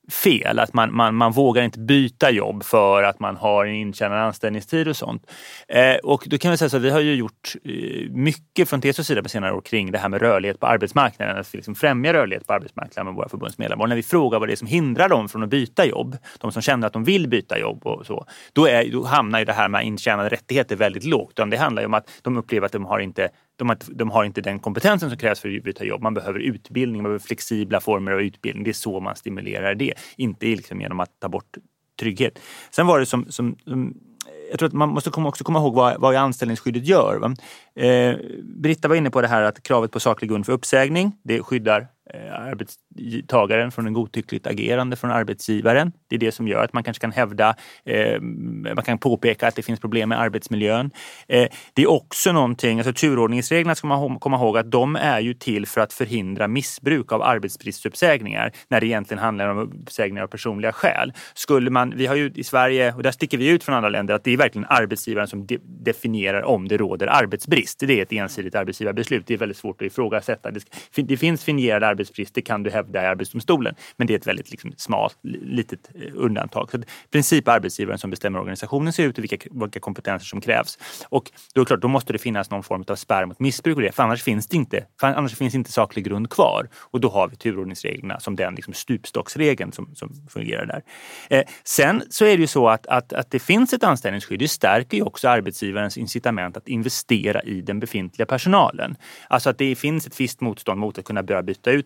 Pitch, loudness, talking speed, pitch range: 120 Hz, -21 LUFS, 225 wpm, 110-135 Hz